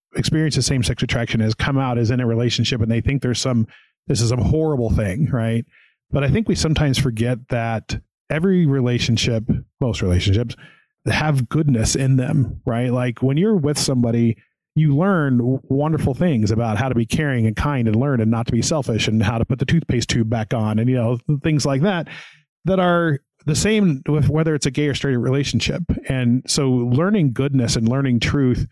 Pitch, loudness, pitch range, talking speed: 130 Hz, -19 LUFS, 115-145 Hz, 200 wpm